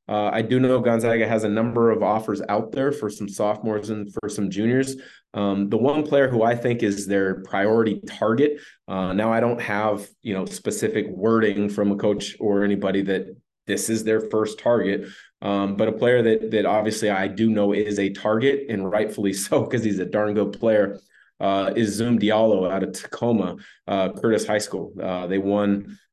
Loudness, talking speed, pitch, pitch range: -22 LUFS, 200 wpm, 105 Hz, 100-115 Hz